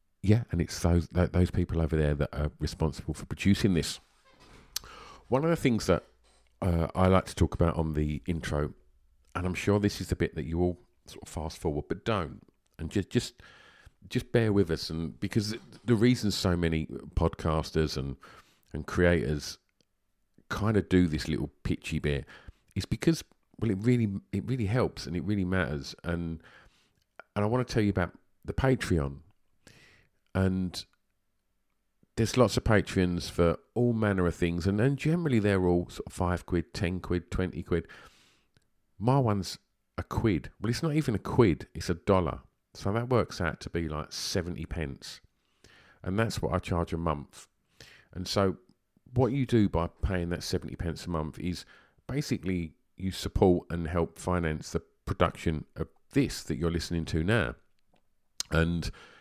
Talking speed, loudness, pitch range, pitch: 175 wpm, -30 LUFS, 80-105 Hz, 90 Hz